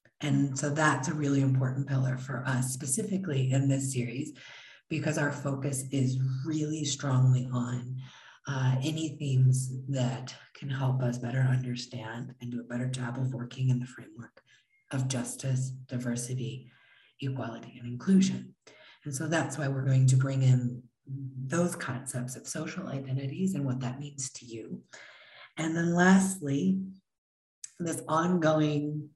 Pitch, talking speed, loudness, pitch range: 130 Hz, 145 wpm, -30 LUFS, 125-145 Hz